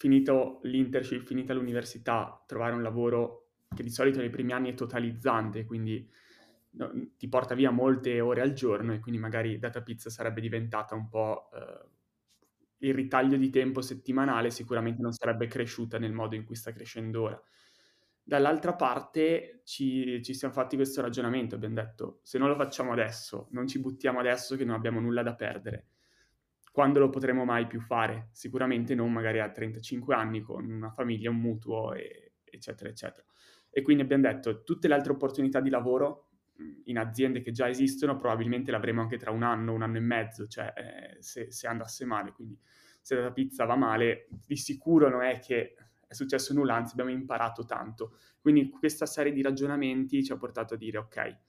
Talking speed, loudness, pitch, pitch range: 180 wpm, -30 LUFS, 120 Hz, 115-135 Hz